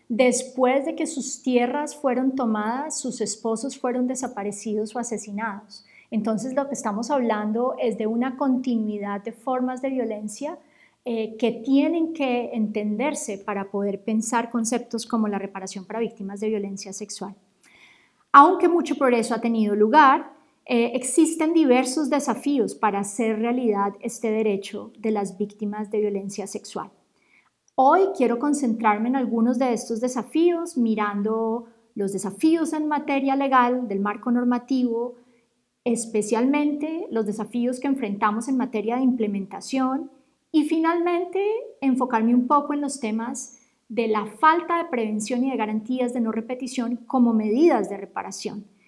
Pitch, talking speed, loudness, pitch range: 240 Hz, 140 wpm, -23 LUFS, 215-270 Hz